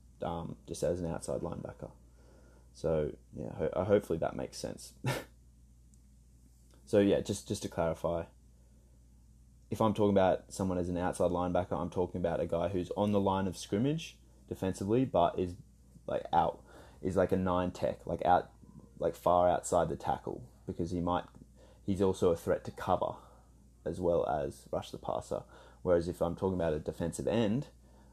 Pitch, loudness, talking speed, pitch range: 85 Hz, -33 LUFS, 170 wpm, 65-95 Hz